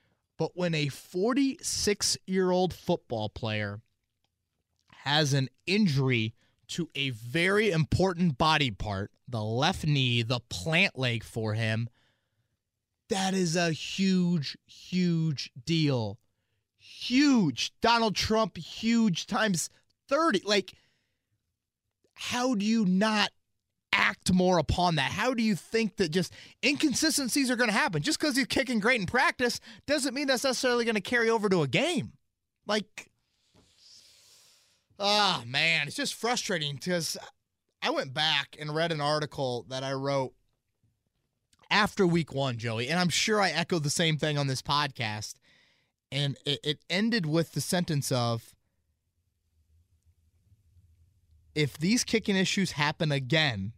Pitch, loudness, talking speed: 150 Hz, -28 LUFS, 135 wpm